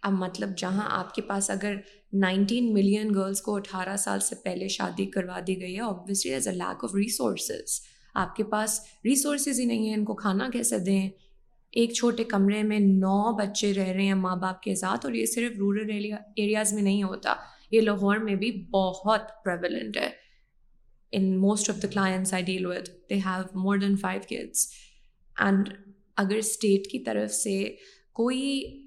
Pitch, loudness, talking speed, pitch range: 200 Hz, -27 LUFS, 180 wpm, 190-215 Hz